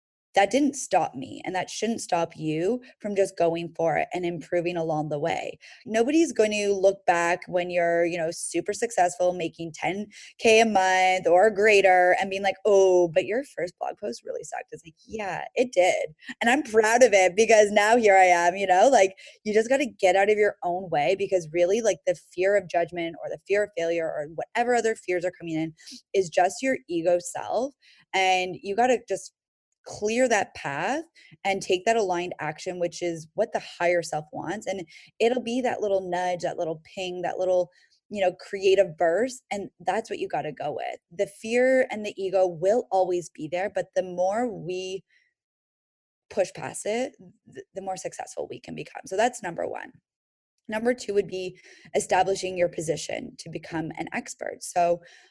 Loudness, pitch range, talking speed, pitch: -25 LUFS, 175-220 Hz, 195 wpm, 190 Hz